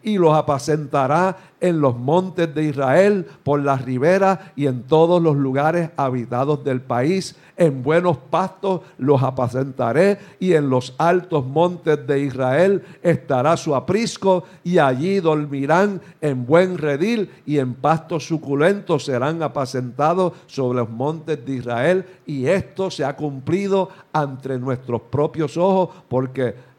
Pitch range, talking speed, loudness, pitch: 135-180 Hz, 135 wpm, -20 LUFS, 155 Hz